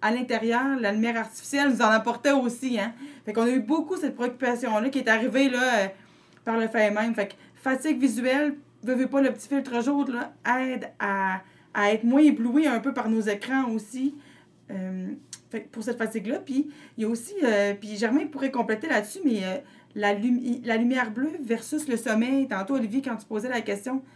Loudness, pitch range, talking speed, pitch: -26 LUFS, 220-270 Hz, 205 wpm, 245 Hz